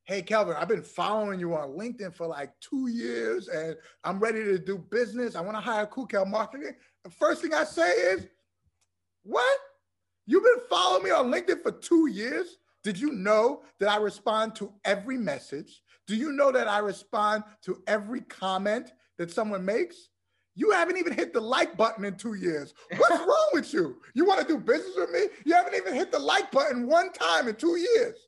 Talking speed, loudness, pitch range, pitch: 200 wpm, -27 LUFS, 195-315 Hz, 225 Hz